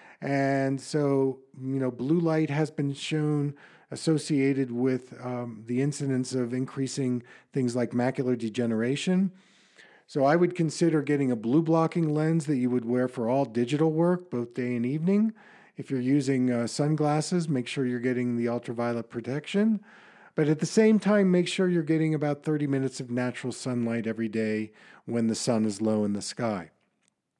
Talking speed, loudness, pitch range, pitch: 170 wpm, -27 LUFS, 125-155 Hz, 135 Hz